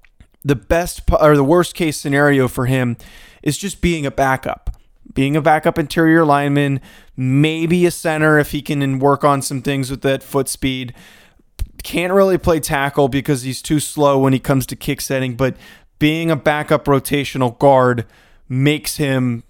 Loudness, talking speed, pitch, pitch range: -16 LUFS, 170 wpm, 145 Hz, 135-155 Hz